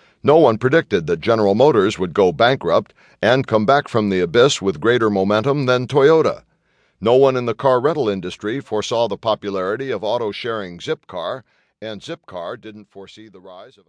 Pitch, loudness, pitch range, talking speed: 110 Hz, -17 LUFS, 105-130 Hz, 175 wpm